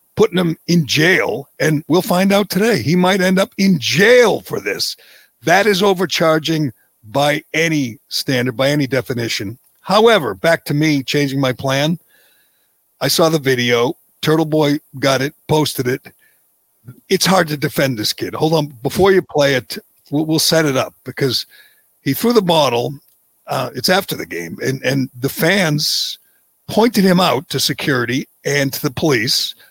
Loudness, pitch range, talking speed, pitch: -16 LUFS, 135-180 Hz, 165 wpm, 150 Hz